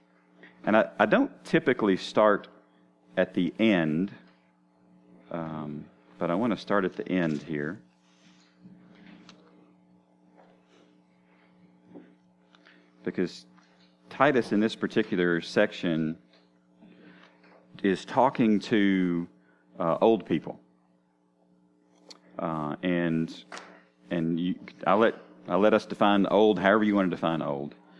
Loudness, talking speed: -27 LUFS, 105 wpm